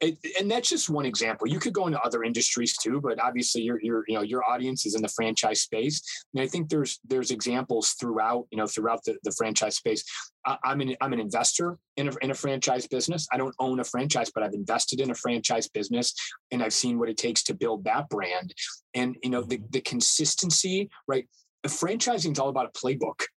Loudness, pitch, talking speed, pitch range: -27 LUFS, 130 Hz, 220 wpm, 120-150 Hz